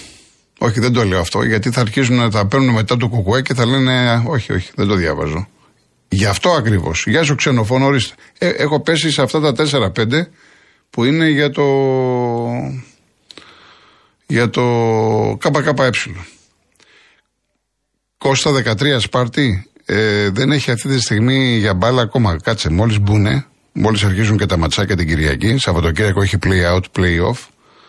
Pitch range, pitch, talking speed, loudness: 105-135 Hz, 120 Hz, 150 wpm, -15 LUFS